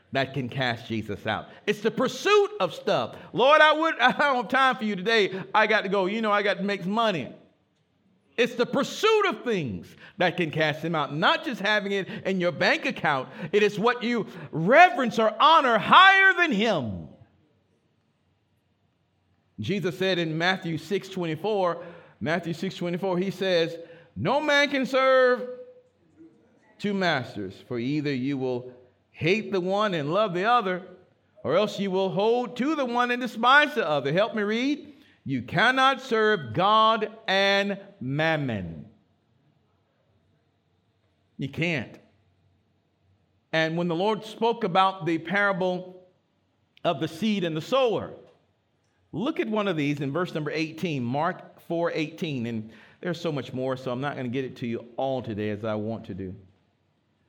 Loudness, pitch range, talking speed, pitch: -24 LUFS, 130-220 Hz, 165 wpm, 180 Hz